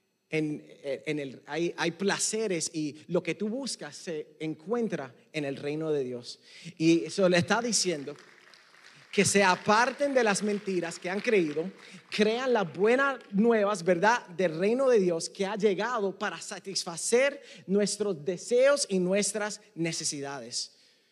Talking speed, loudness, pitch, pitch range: 145 wpm, -28 LUFS, 190 Hz, 160-210 Hz